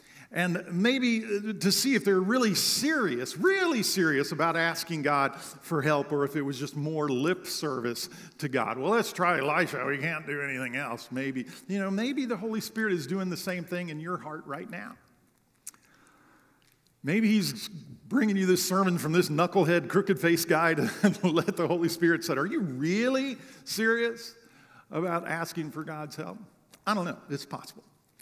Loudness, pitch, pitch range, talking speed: -28 LUFS, 175 Hz, 150-205 Hz, 175 wpm